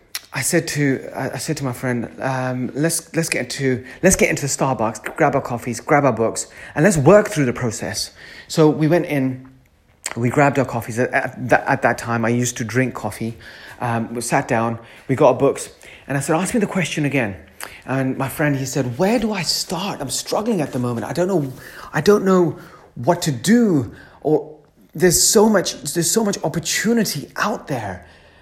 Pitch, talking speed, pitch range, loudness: 140 Hz, 200 wpm, 125-170 Hz, -19 LUFS